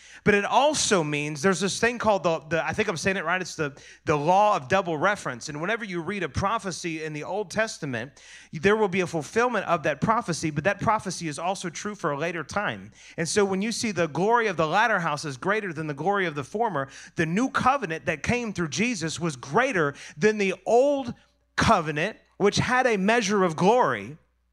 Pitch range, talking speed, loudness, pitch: 160-210 Hz, 220 wpm, -25 LUFS, 185 Hz